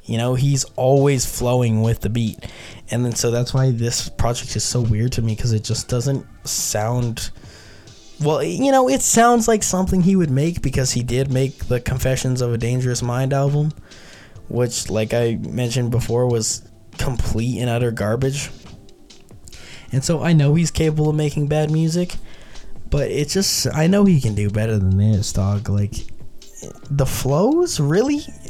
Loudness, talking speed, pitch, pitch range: -19 LUFS, 175 wpm, 125 Hz, 110-145 Hz